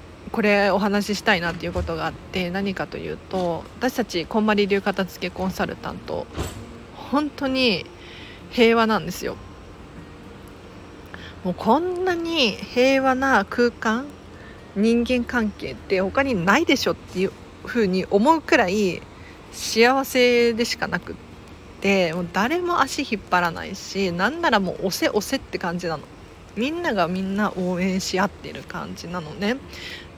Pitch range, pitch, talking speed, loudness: 180-245 Hz, 205 Hz, 285 characters per minute, -22 LUFS